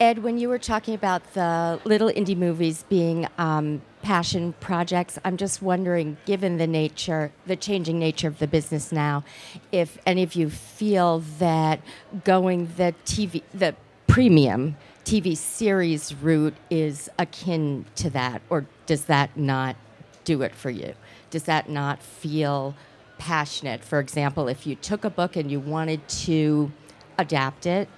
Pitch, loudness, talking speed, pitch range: 160 Hz, -24 LUFS, 150 wpm, 145-180 Hz